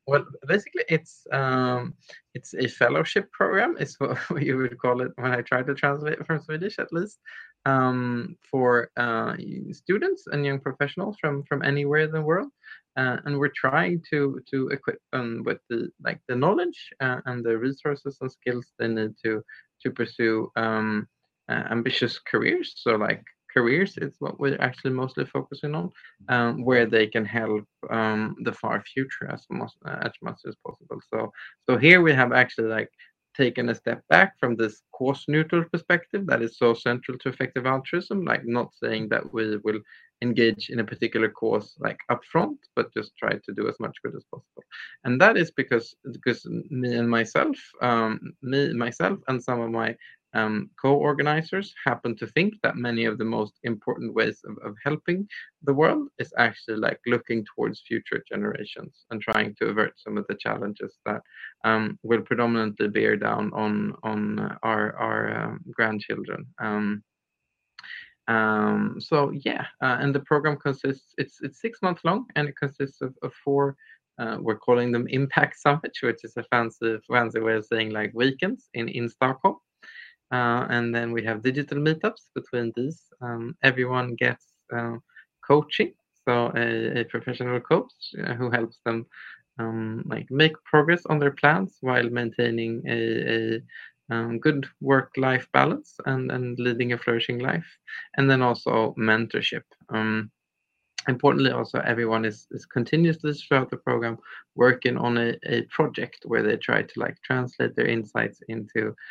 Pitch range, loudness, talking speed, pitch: 115-145 Hz, -25 LUFS, 170 wpm, 125 Hz